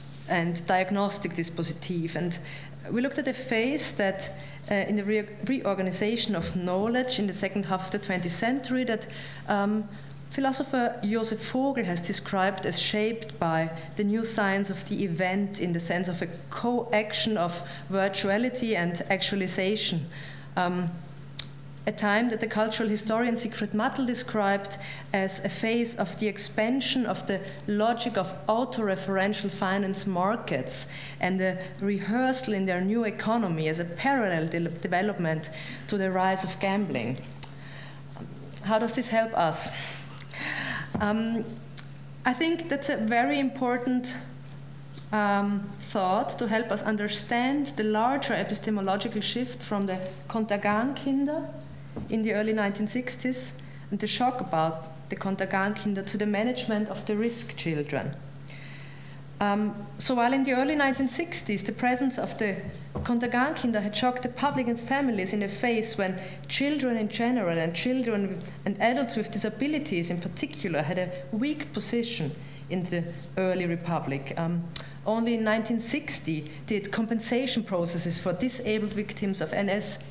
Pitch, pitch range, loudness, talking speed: 200 Hz, 170-225 Hz, -28 LUFS, 145 wpm